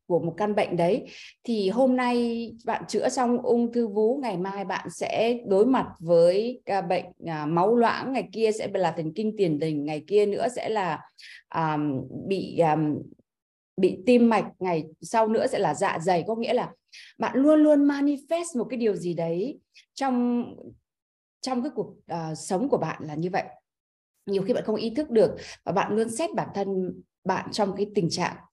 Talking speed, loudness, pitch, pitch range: 190 wpm, -26 LUFS, 210 Hz, 175-235 Hz